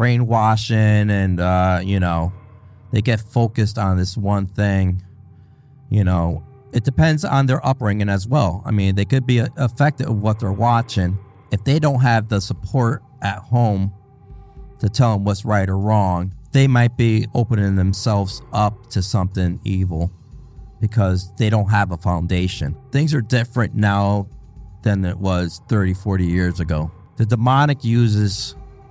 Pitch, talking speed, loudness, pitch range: 105 Hz, 155 wpm, -19 LUFS, 95-120 Hz